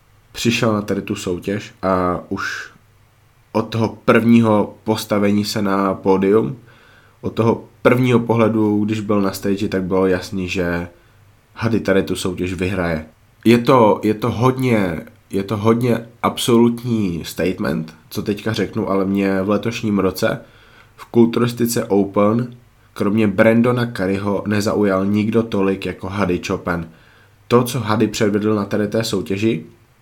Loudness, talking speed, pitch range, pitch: -18 LUFS, 140 wpm, 95-115 Hz, 105 Hz